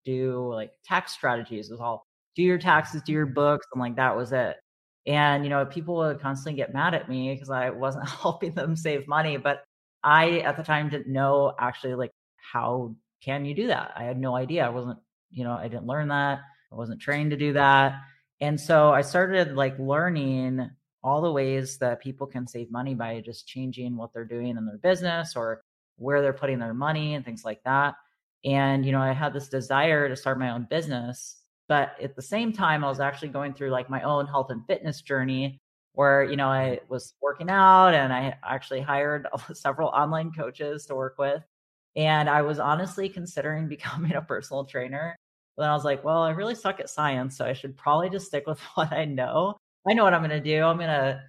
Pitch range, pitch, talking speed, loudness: 130-150 Hz, 140 Hz, 220 wpm, -26 LUFS